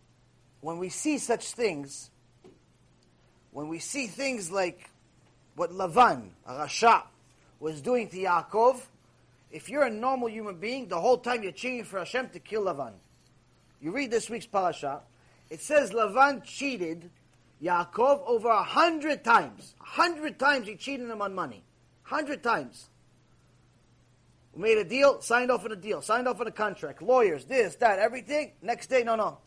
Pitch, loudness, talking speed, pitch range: 230 Hz, -28 LUFS, 165 wpm, 175-270 Hz